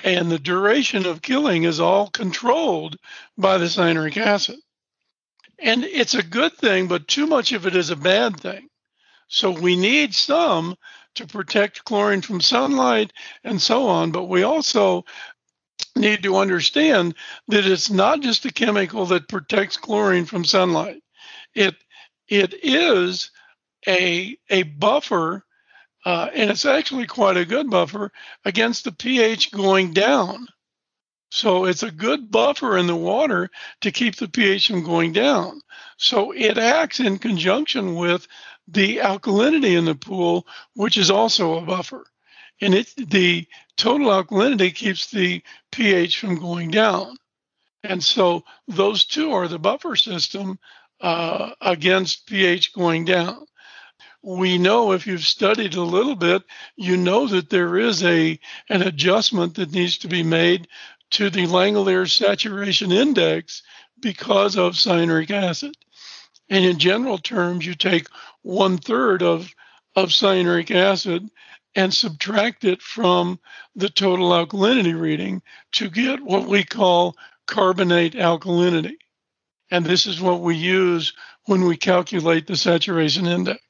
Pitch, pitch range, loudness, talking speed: 195 Hz, 180-225 Hz, -19 LUFS, 140 wpm